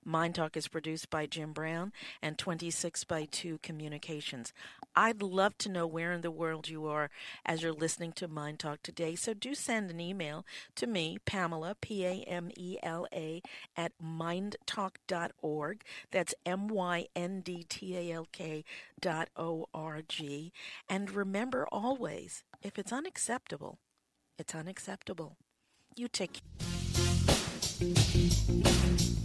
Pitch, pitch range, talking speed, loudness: 170 Hz, 160-190 Hz, 145 wpm, -36 LUFS